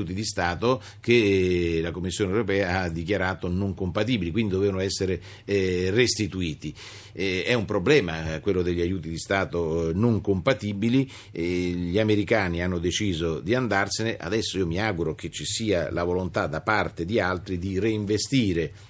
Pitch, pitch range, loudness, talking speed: 95 Hz, 90-105 Hz, -25 LUFS, 145 wpm